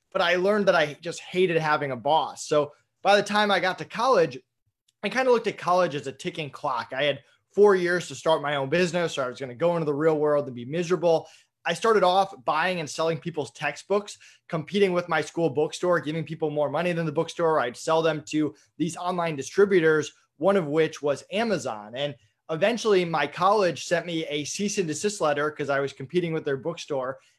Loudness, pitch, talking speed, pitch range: -25 LUFS, 160 Hz, 220 wpm, 145-180 Hz